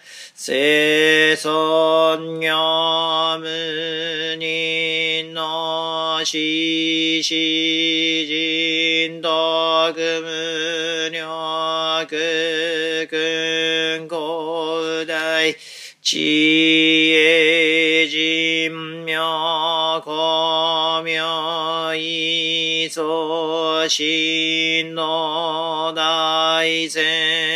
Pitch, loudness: 160 Hz, -18 LUFS